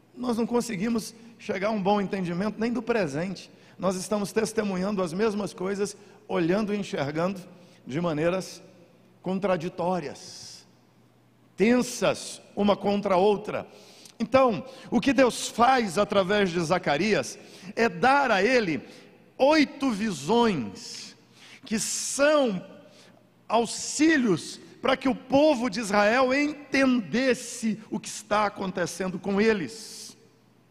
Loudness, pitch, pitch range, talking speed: -26 LUFS, 210 Hz, 190-240 Hz, 115 wpm